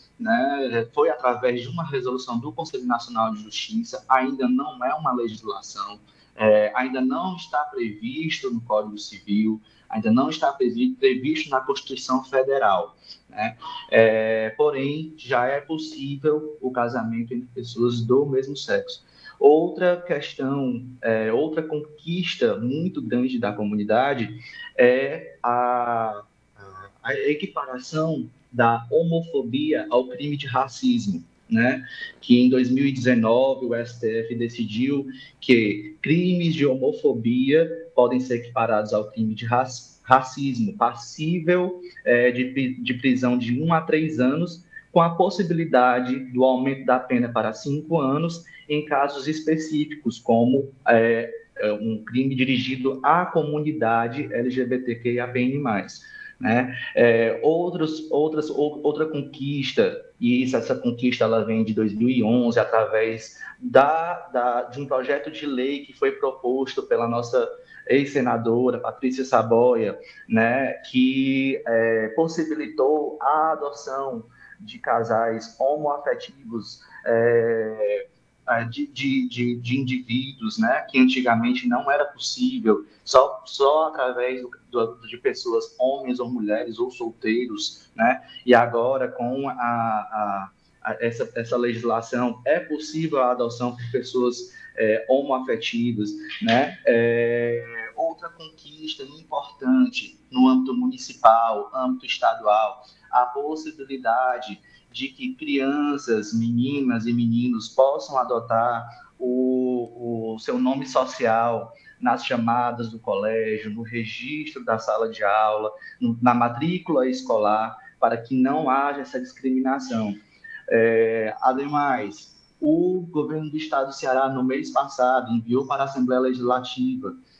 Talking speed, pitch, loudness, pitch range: 120 wpm, 130 Hz, -23 LUFS, 120-155 Hz